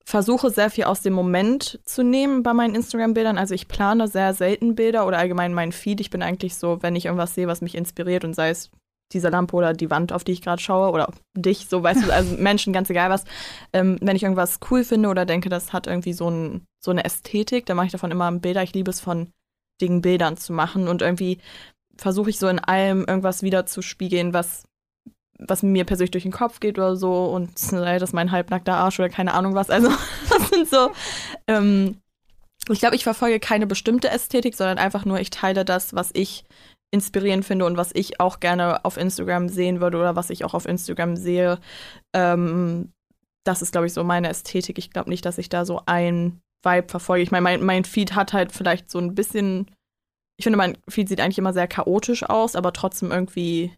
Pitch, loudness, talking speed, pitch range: 185 Hz, -22 LUFS, 220 wpm, 175-200 Hz